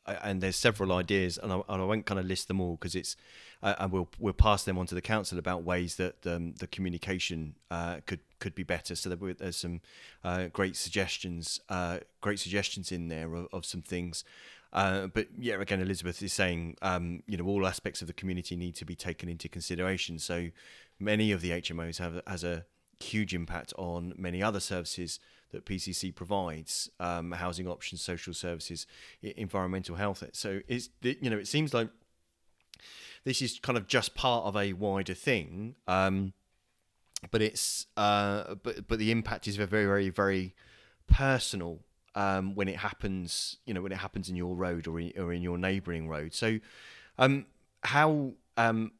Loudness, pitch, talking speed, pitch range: -33 LUFS, 95 Hz, 185 wpm, 85-100 Hz